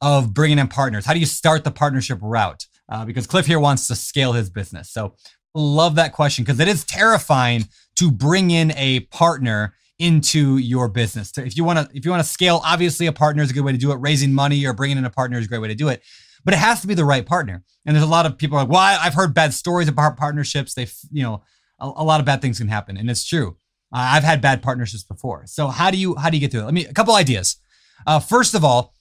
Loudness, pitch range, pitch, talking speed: -18 LUFS, 125-160 Hz, 140 Hz, 275 wpm